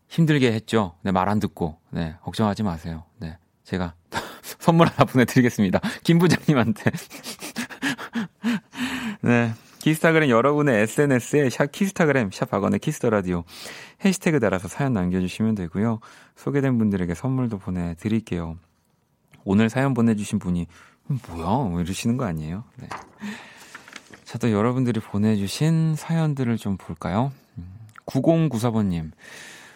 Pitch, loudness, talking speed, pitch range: 115 Hz, -23 LUFS, 295 characters per minute, 95-145 Hz